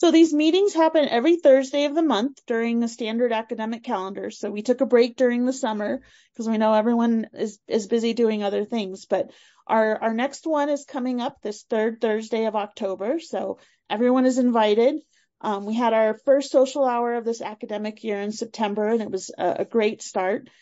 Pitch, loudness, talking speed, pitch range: 230 Hz, -23 LUFS, 200 wpm, 215-265 Hz